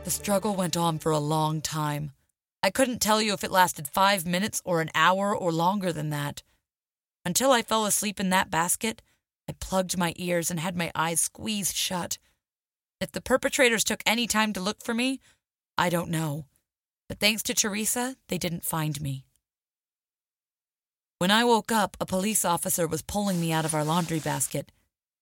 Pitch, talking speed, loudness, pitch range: 180 Hz, 185 wpm, -26 LUFS, 160-210 Hz